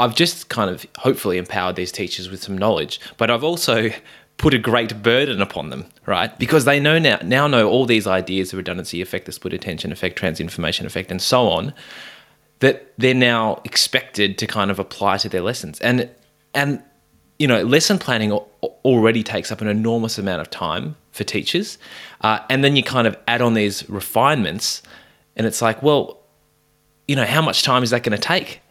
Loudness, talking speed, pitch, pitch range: -19 LUFS, 195 wpm, 115 Hz, 105-130 Hz